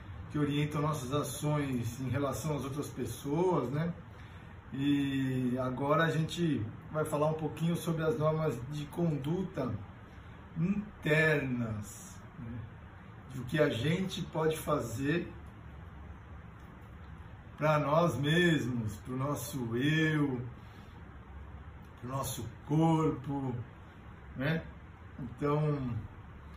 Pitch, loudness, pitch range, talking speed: 130 Hz, -33 LUFS, 105-150 Hz, 100 wpm